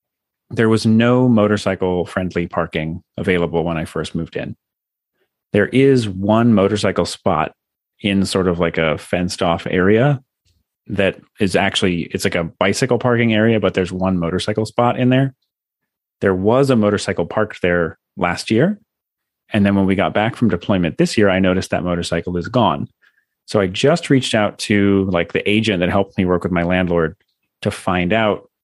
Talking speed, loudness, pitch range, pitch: 175 wpm, -17 LUFS, 90-110 Hz, 100 Hz